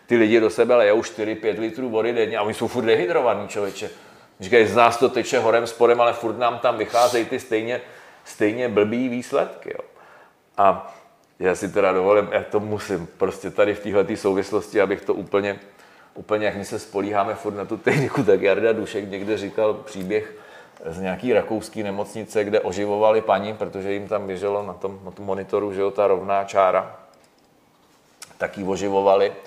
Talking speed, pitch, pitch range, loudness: 180 wpm, 105 Hz, 100-115 Hz, -21 LUFS